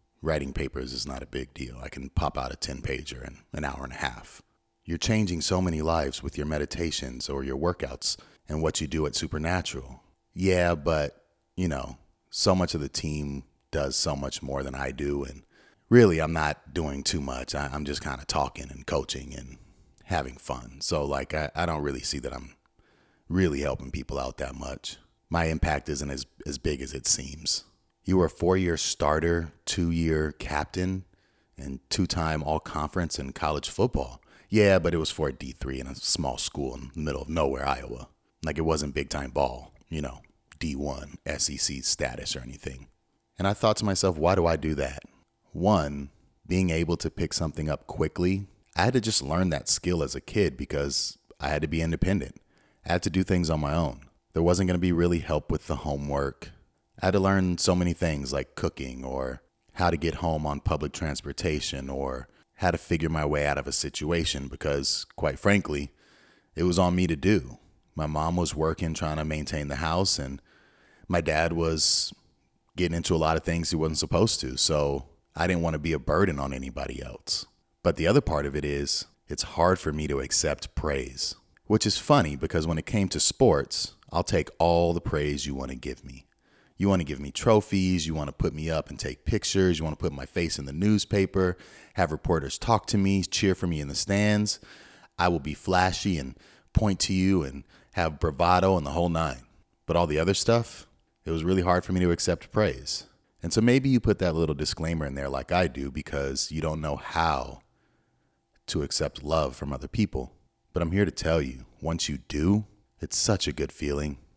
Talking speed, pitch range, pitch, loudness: 205 wpm, 70-90 Hz, 80 Hz, -27 LUFS